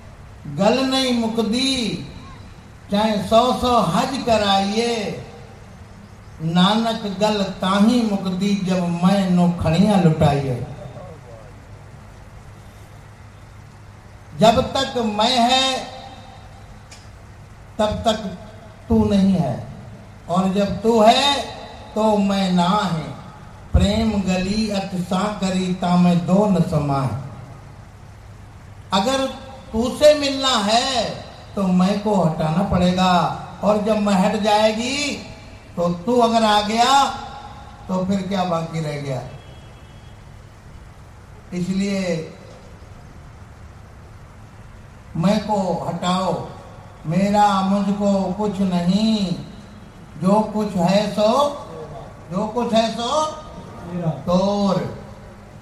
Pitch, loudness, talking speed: 180 Hz, -19 LUFS, 95 wpm